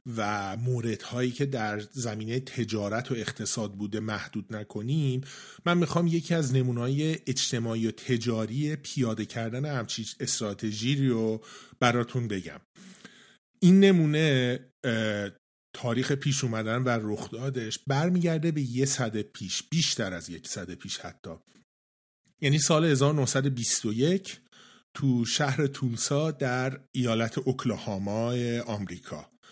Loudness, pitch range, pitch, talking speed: -27 LUFS, 110-140 Hz, 125 Hz, 110 wpm